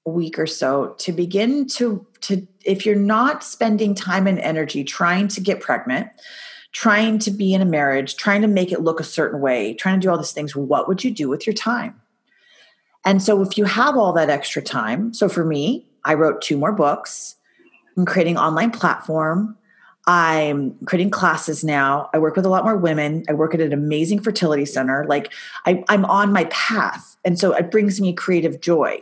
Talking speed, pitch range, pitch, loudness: 205 wpm, 160-210 Hz, 185 Hz, -19 LUFS